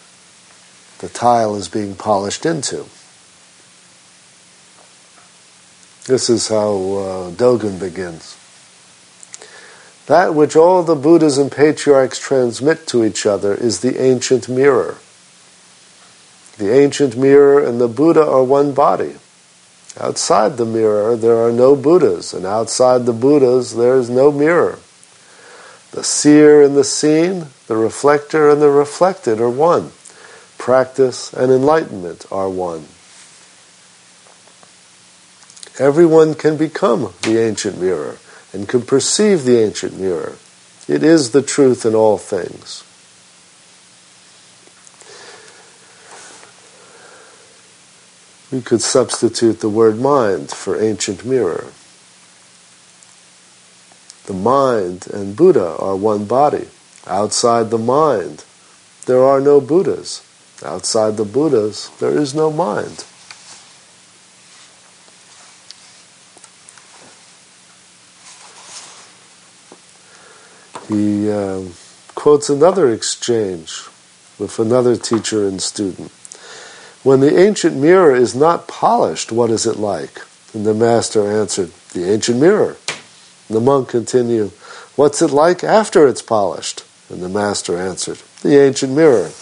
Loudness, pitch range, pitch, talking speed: -14 LUFS, 105-145 Hz, 125 Hz, 110 wpm